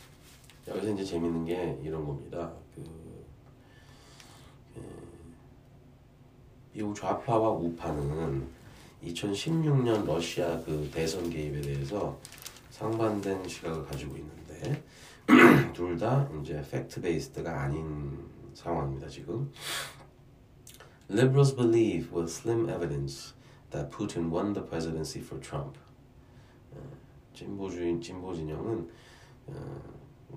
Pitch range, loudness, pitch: 80-115 Hz, -30 LUFS, 85 Hz